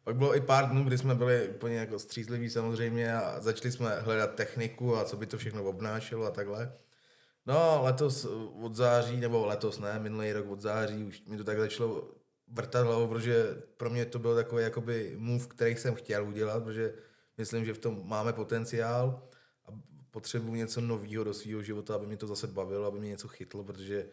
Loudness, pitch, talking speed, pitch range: -33 LUFS, 115 Hz, 195 wpm, 110-120 Hz